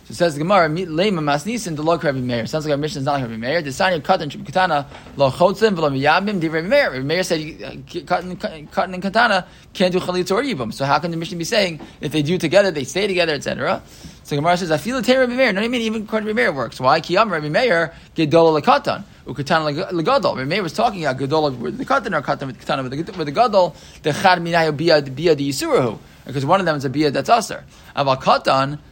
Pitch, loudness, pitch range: 165 Hz, -19 LUFS, 150-190 Hz